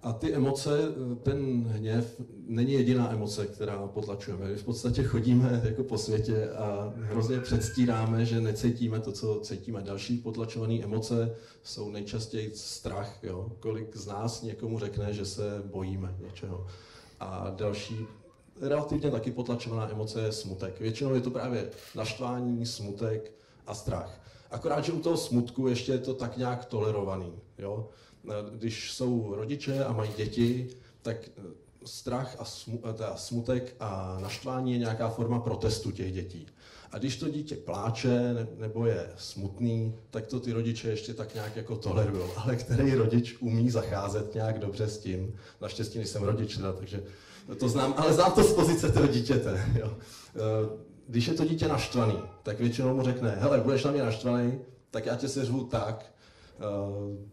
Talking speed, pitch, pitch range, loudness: 155 wpm, 115 Hz, 105-125 Hz, -31 LUFS